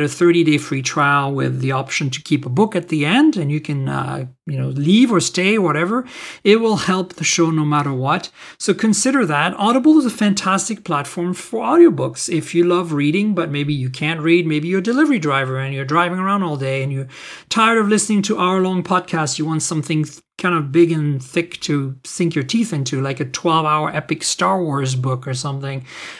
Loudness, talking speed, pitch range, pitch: -17 LUFS, 215 wpm, 145-190 Hz, 165 Hz